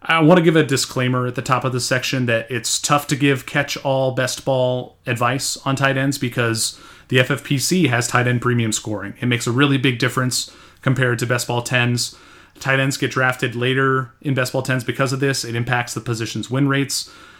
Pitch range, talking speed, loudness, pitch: 120-135 Hz, 215 wpm, -19 LUFS, 130 Hz